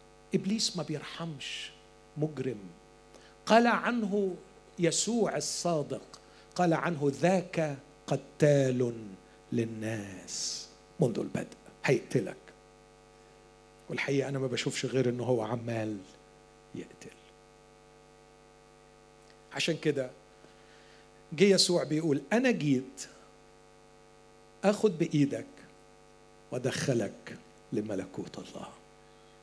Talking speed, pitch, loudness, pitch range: 75 wpm, 145 Hz, -31 LUFS, 120-175 Hz